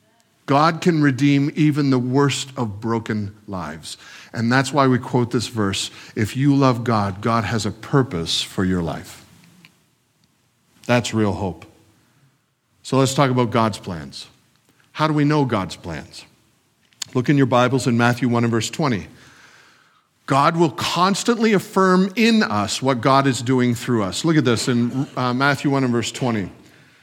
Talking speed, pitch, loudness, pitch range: 165 wpm, 125 Hz, -19 LUFS, 110-140 Hz